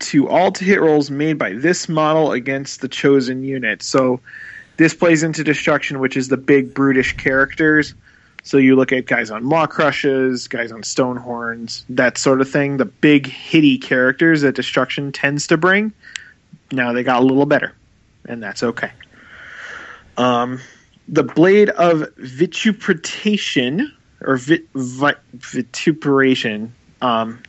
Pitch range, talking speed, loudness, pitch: 130-155 Hz, 150 wpm, -16 LUFS, 135 Hz